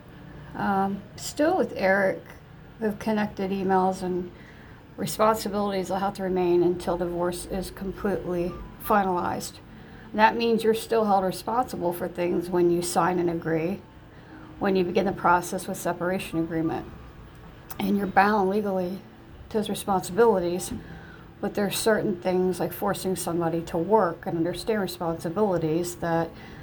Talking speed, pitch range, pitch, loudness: 135 wpm, 175-200 Hz, 185 Hz, -26 LUFS